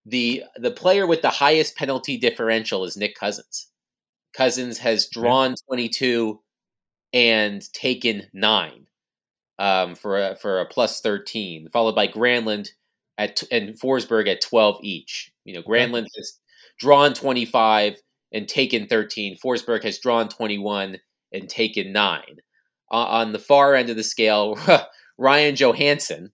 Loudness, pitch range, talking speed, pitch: -20 LUFS, 105-130 Hz, 145 wpm, 115 Hz